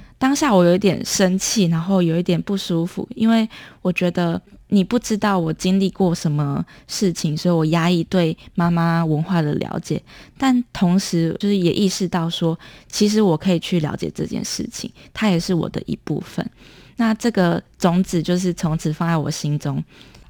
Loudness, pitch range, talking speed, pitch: -20 LUFS, 165-195 Hz, 265 characters per minute, 180 Hz